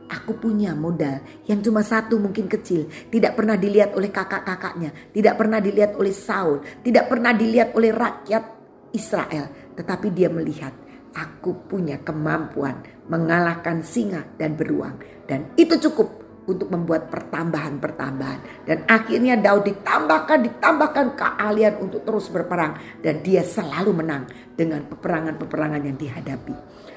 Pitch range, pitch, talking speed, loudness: 160-220 Hz, 195 Hz, 130 wpm, -22 LUFS